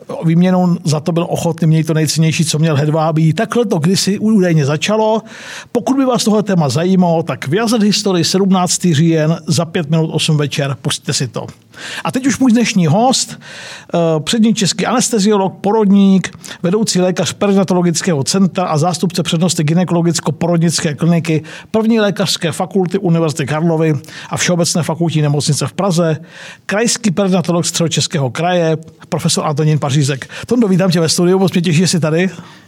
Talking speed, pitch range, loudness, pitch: 155 wpm, 160-195 Hz, -14 LUFS, 175 Hz